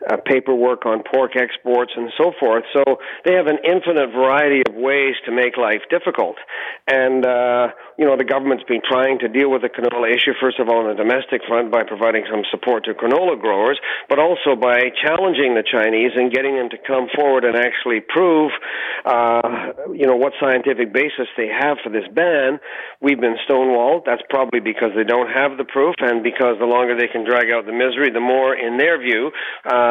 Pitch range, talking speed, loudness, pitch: 120-135 Hz, 205 wpm, -17 LUFS, 125 Hz